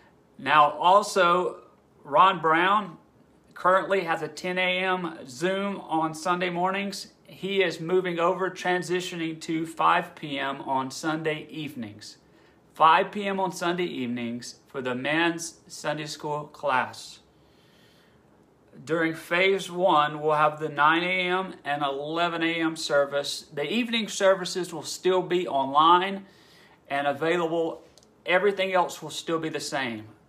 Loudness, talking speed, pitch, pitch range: -25 LUFS, 125 wpm, 165 Hz, 150-185 Hz